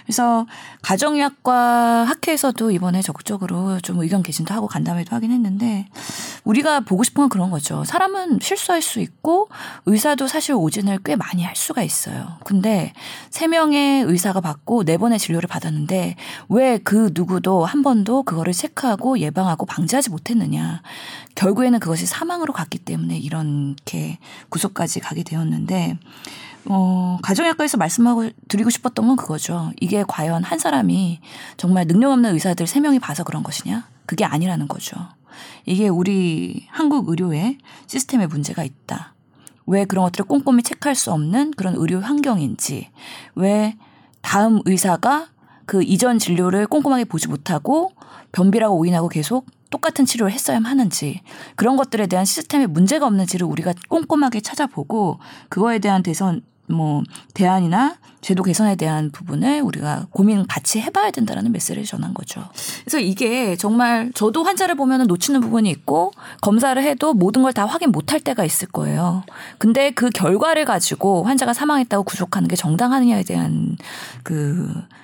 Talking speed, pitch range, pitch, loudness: 350 characters per minute, 180-260 Hz, 210 Hz, -19 LUFS